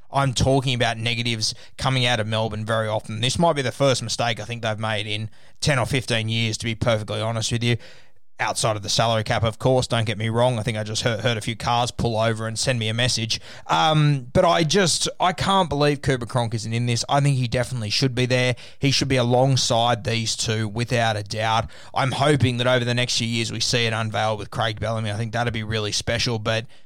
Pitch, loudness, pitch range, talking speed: 120 Hz, -22 LUFS, 110-130 Hz, 240 wpm